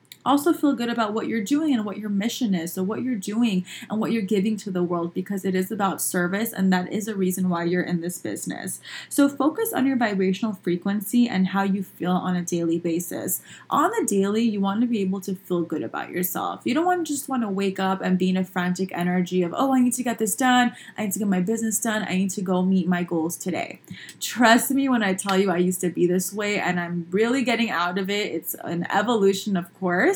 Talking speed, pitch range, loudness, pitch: 255 wpm, 180-230 Hz, -24 LUFS, 195 Hz